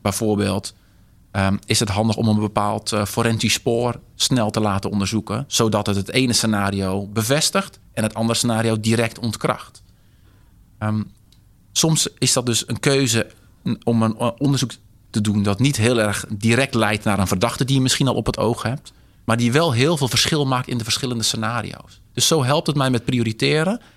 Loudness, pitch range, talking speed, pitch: -20 LUFS, 105-125 Hz, 185 wpm, 115 Hz